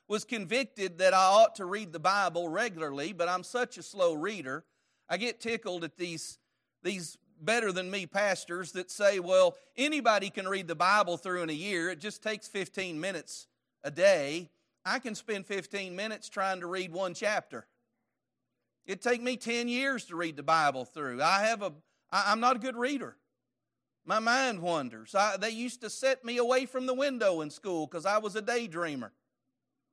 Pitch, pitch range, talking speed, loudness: 200 Hz, 180-235 Hz, 185 wpm, -31 LUFS